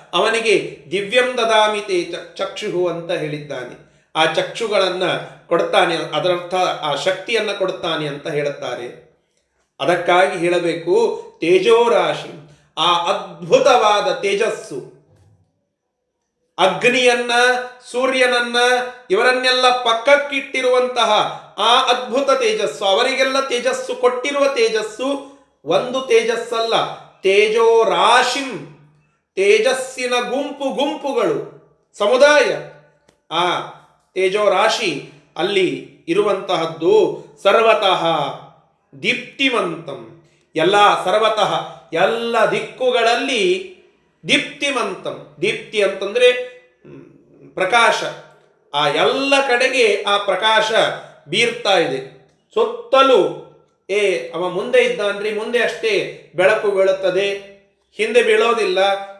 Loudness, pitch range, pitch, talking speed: -17 LUFS, 190-285 Hz, 235 Hz, 75 wpm